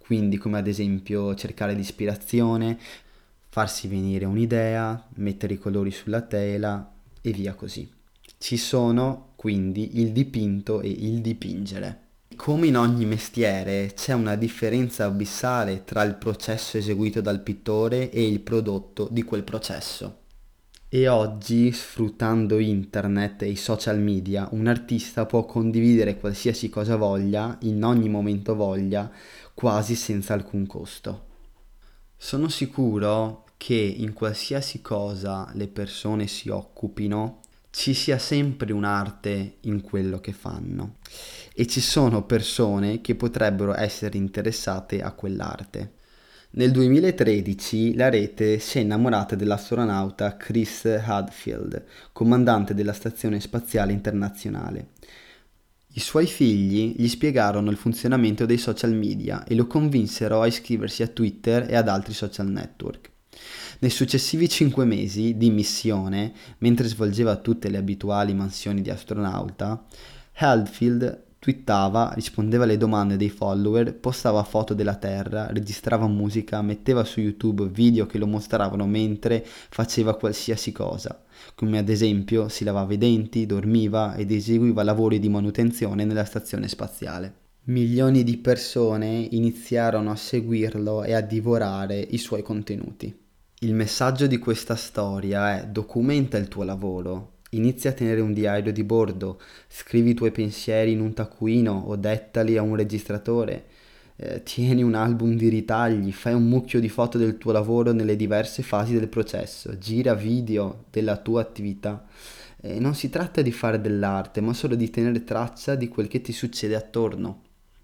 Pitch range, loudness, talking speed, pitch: 105-115 Hz, -24 LUFS, 135 wpm, 110 Hz